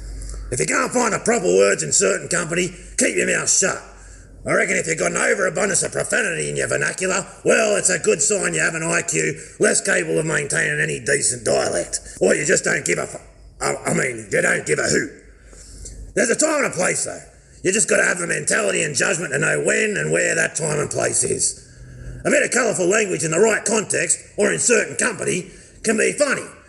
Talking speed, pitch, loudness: 225 wpm, 255 Hz, -19 LUFS